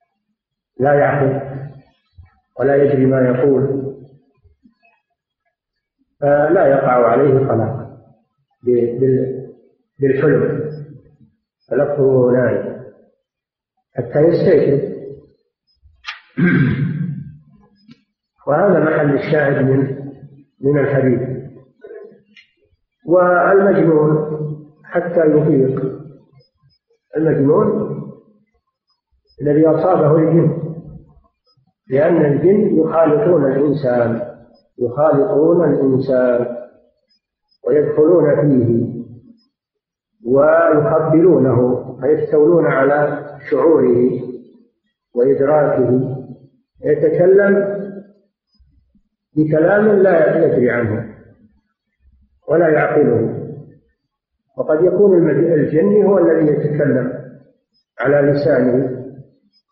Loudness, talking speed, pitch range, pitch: -15 LUFS, 55 wpm, 130-185 Hz, 145 Hz